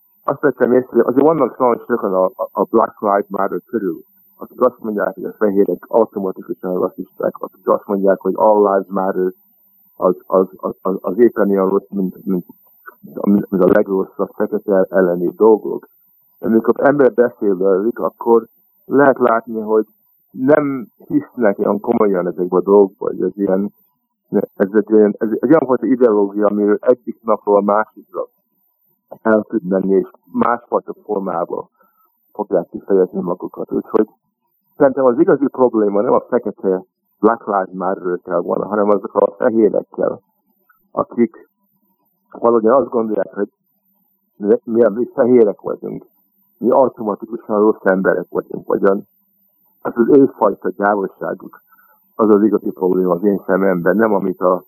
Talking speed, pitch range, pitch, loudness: 145 wpm, 95-150 Hz, 110 Hz, -16 LUFS